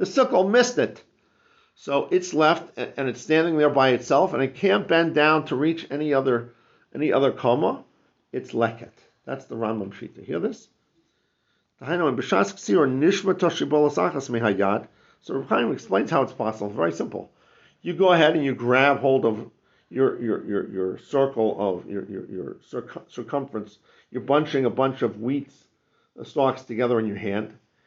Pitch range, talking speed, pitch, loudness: 120-160 Hz, 155 wpm, 135 Hz, -23 LUFS